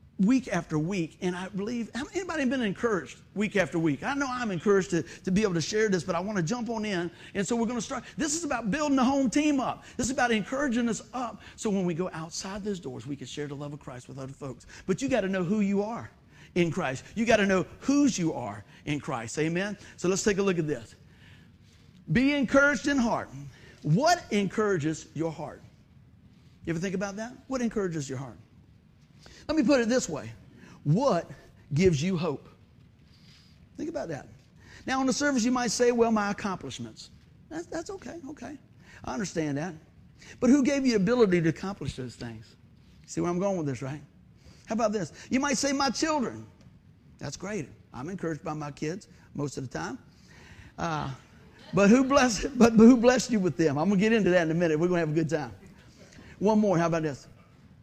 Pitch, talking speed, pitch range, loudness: 190 Hz, 215 wpm, 155-240 Hz, -27 LUFS